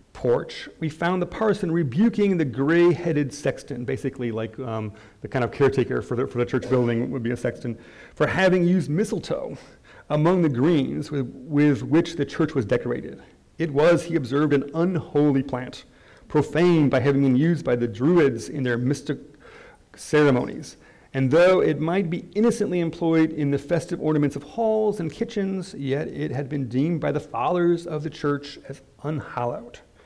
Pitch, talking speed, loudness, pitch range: 150 Hz, 175 wpm, -23 LUFS, 135-170 Hz